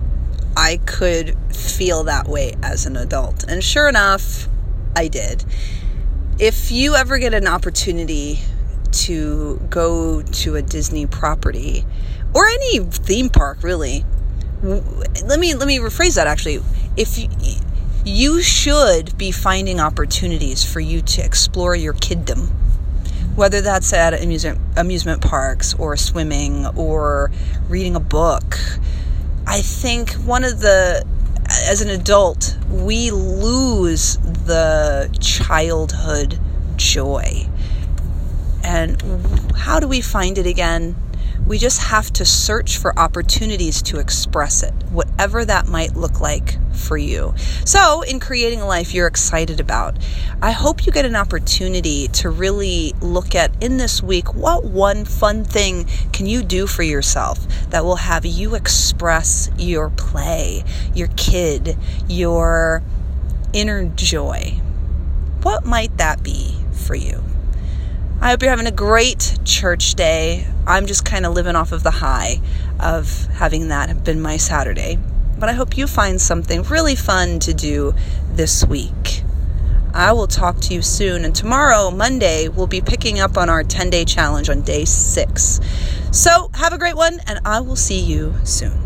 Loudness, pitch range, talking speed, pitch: -17 LUFS, 70-90 Hz, 145 wpm, 75 Hz